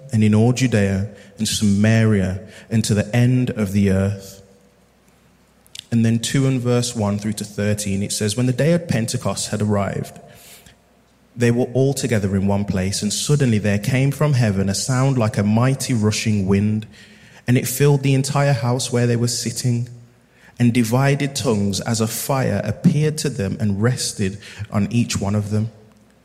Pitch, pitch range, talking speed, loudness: 110 Hz, 100-125 Hz, 175 wpm, -19 LUFS